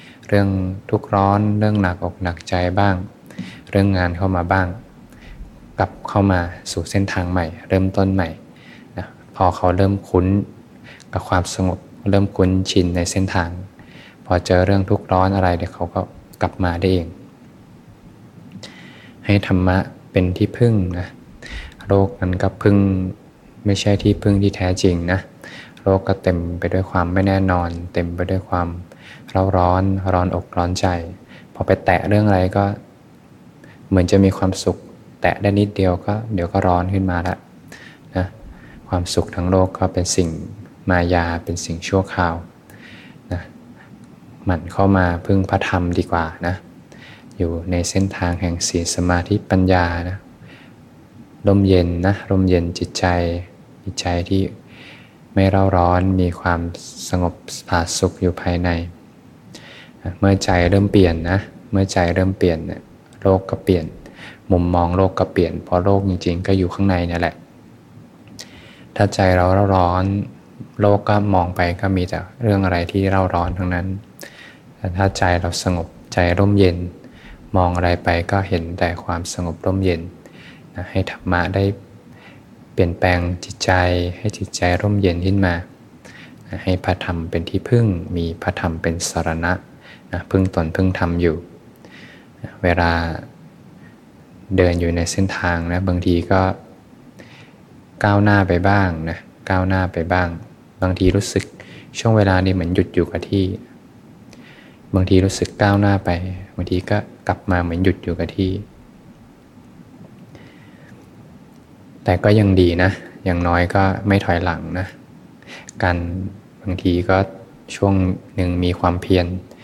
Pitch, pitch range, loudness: 90 Hz, 90-95 Hz, -19 LUFS